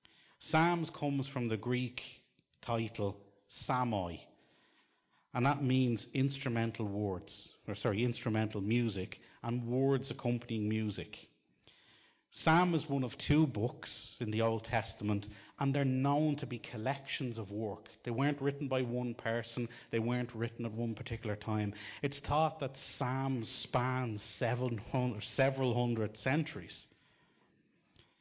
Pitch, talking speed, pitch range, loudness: 120 Hz, 125 wpm, 110-135 Hz, -36 LUFS